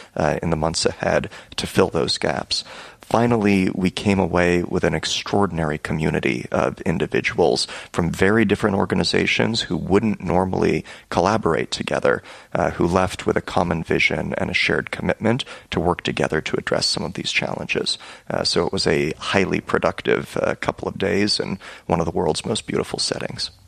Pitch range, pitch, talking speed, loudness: 85-105 Hz, 95 Hz, 170 wpm, -21 LUFS